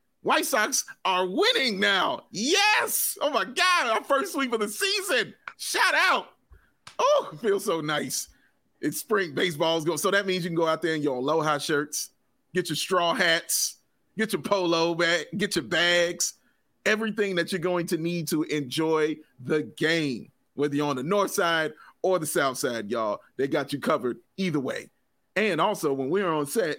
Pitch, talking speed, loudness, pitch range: 170 Hz, 180 wpm, -25 LUFS, 155-200 Hz